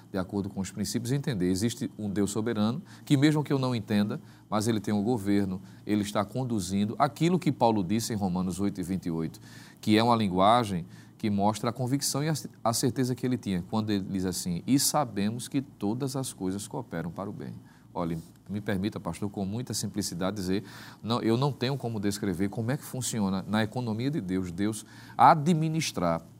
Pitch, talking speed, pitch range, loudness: 110 Hz, 195 wpm, 100-125 Hz, -29 LUFS